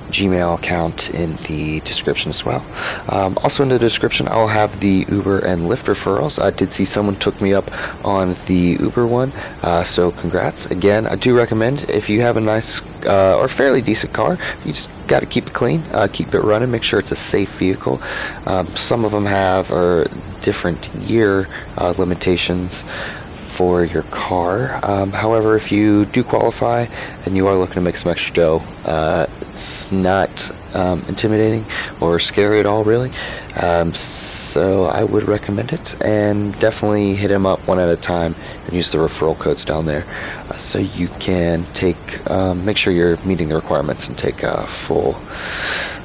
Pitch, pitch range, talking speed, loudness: 95 Hz, 90-105 Hz, 185 wpm, -17 LUFS